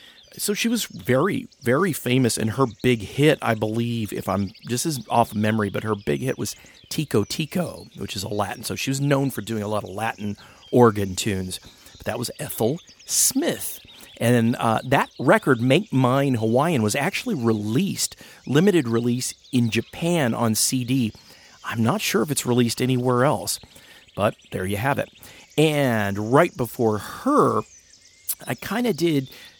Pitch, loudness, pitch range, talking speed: 120 Hz, -22 LUFS, 110-135 Hz, 170 wpm